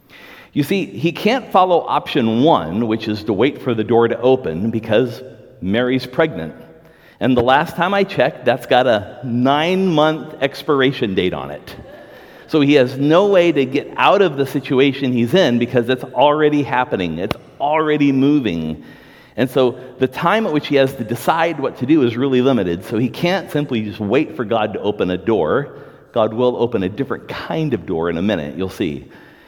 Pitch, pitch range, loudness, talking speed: 135 Hz, 120-150 Hz, -17 LUFS, 195 wpm